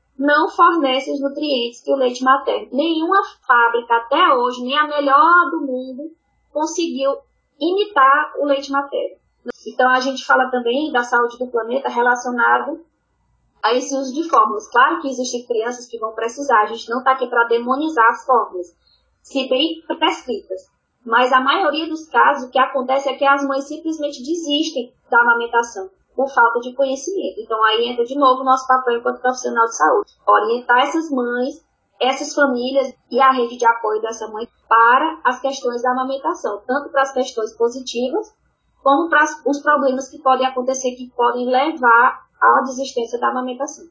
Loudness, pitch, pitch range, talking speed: -17 LUFS, 260 Hz, 240-290 Hz, 170 wpm